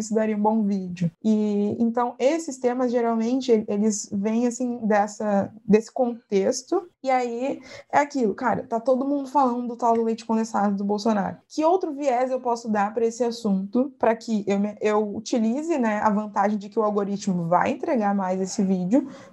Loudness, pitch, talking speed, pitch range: -24 LUFS, 225 Hz, 180 wpm, 210-255 Hz